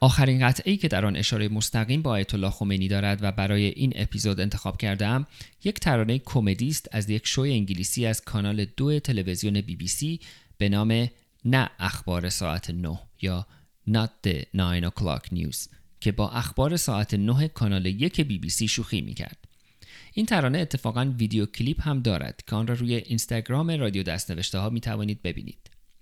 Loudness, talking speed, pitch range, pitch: -26 LUFS, 175 wpm, 100-130 Hz, 110 Hz